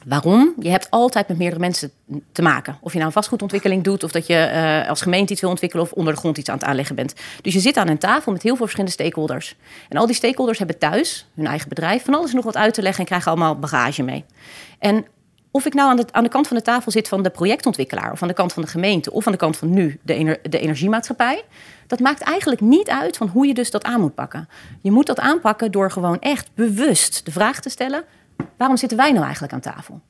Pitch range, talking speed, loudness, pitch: 165-240 Hz, 260 wpm, -19 LUFS, 195 Hz